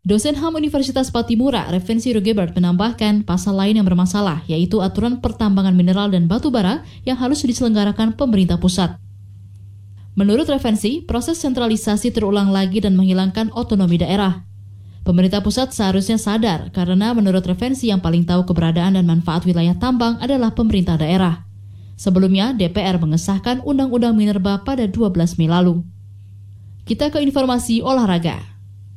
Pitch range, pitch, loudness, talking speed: 175-230 Hz, 200 Hz, -17 LUFS, 135 wpm